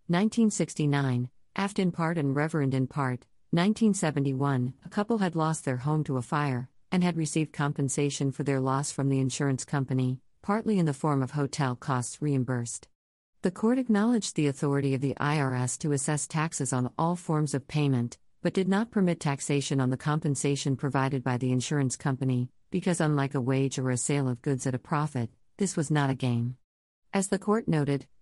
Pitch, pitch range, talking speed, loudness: 140 Hz, 130-160 Hz, 185 wpm, -28 LUFS